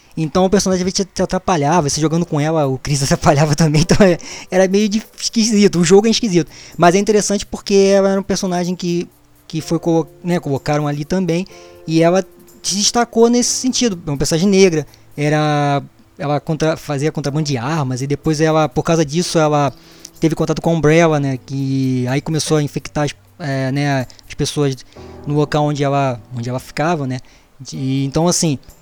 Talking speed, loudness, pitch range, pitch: 185 wpm, -16 LUFS, 140-180 Hz, 155 Hz